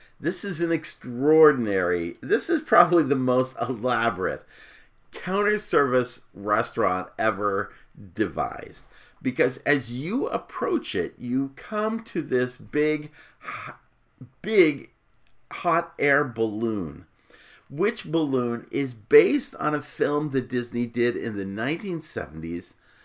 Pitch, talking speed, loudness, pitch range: 140 Hz, 110 wpm, -25 LUFS, 120-170 Hz